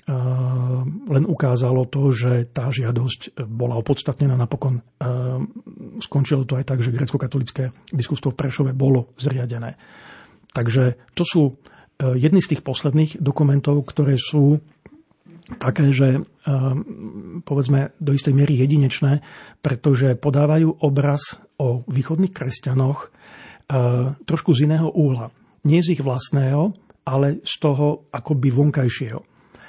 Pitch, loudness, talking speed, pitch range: 140 Hz, -20 LUFS, 115 wpm, 130-150 Hz